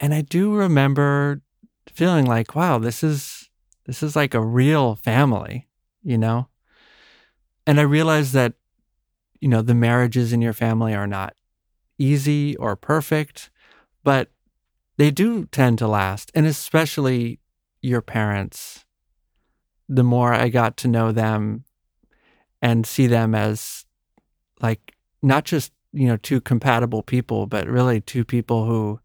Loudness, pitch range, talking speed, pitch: -20 LUFS, 115-145 Hz, 140 wpm, 125 Hz